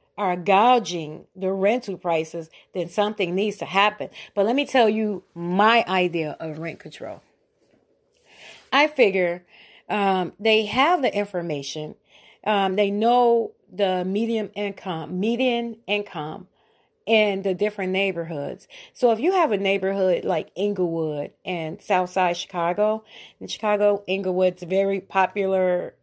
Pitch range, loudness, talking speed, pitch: 180-215 Hz, -23 LUFS, 125 wpm, 195 Hz